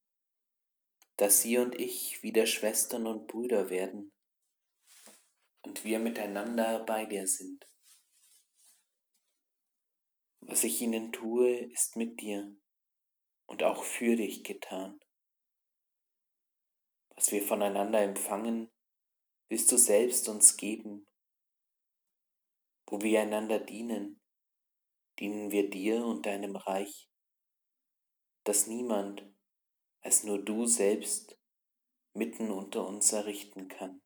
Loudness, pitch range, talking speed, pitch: -30 LUFS, 100-115 Hz, 100 wpm, 105 Hz